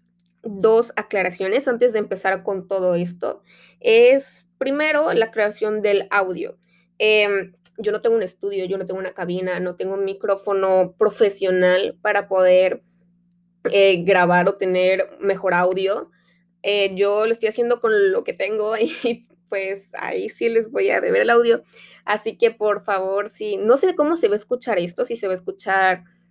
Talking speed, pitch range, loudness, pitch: 175 wpm, 185-230 Hz, -20 LUFS, 200 Hz